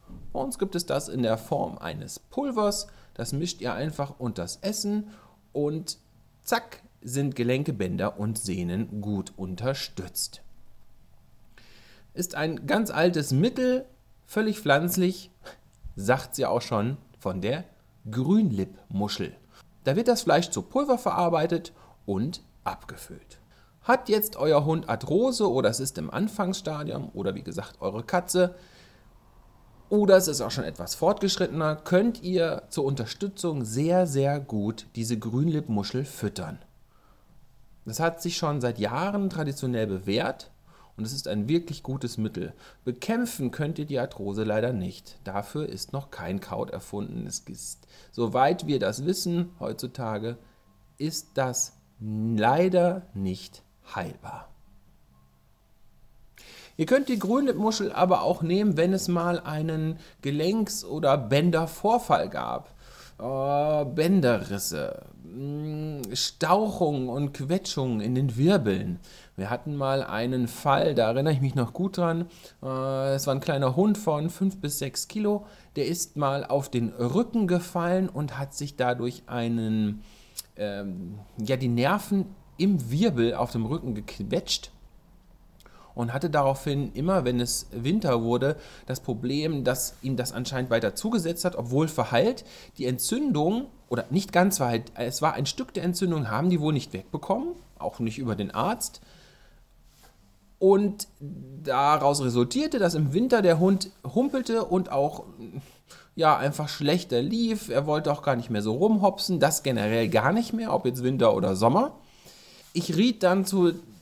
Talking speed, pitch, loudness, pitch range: 140 wpm, 145 Hz, -27 LUFS, 120-180 Hz